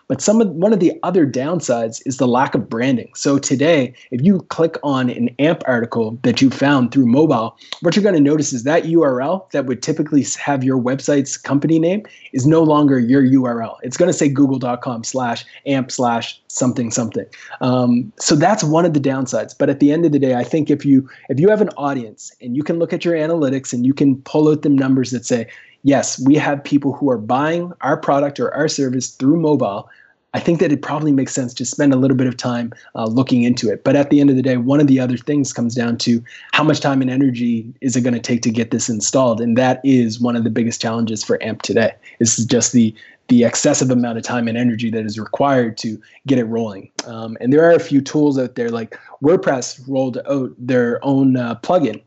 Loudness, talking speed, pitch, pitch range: -17 LUFS, 235 wpm, 135 Hz, 120-145 Hz